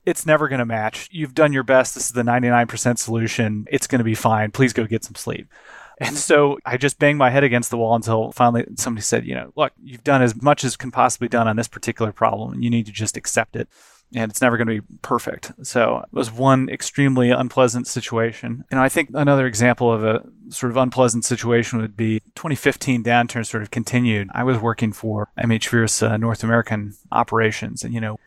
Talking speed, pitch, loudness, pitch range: 220 wpm, 120 Hz, -20 LUFS, 115-130 Hz